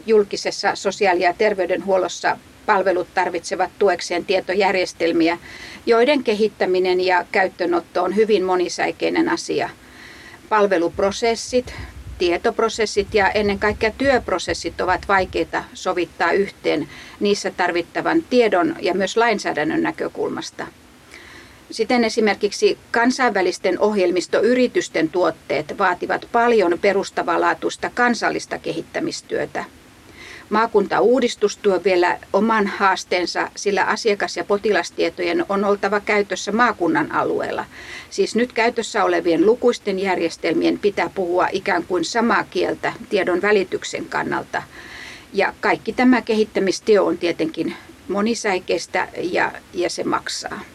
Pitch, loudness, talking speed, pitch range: 200 Hz, -20 LUFS, 100 wpm, 180-230 Hz